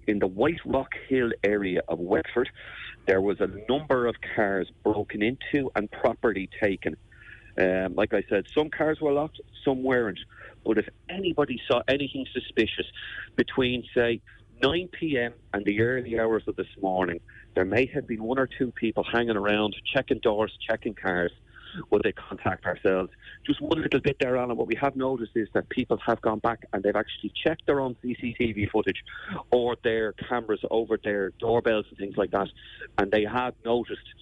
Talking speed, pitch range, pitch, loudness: 180 wpm, 105-130 Hz, 115 Hz, -27 LUFS